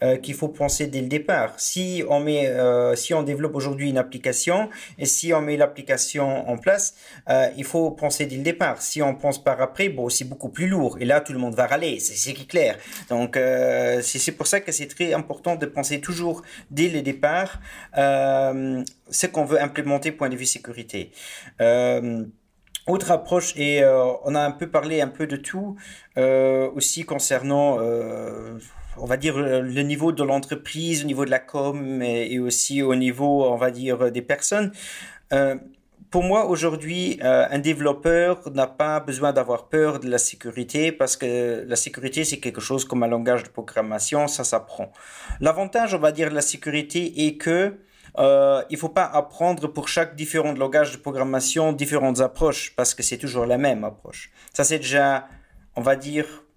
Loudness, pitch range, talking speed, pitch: -22 LUFS, 130-155 Hz, 190 wpm, 140 Hz